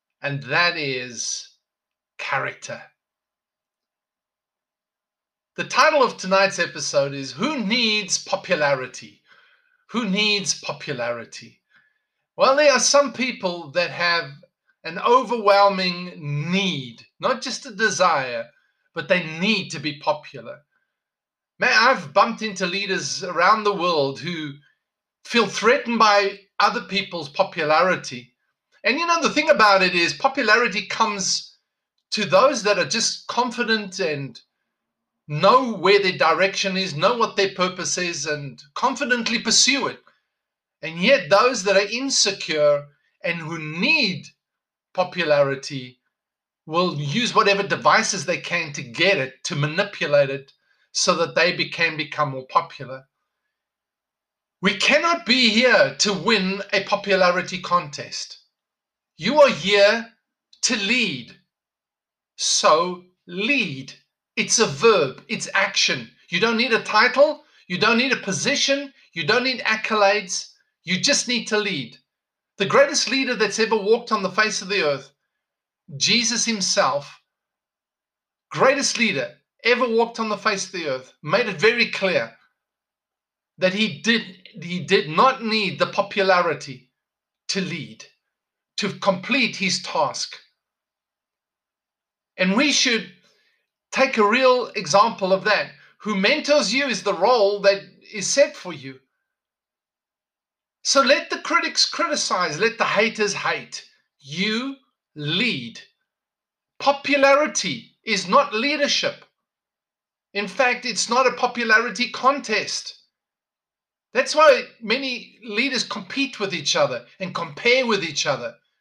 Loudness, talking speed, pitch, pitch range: -20 LUFS, 125 wpm, 205 Hz, 175-235 Hz